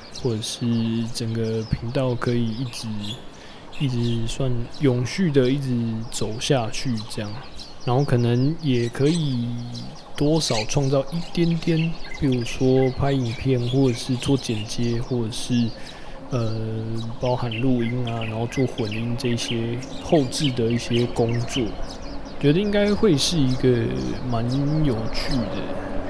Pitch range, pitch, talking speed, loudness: 115-135 Hz, 120 Hz, 195 characters per minute, -23 LUFS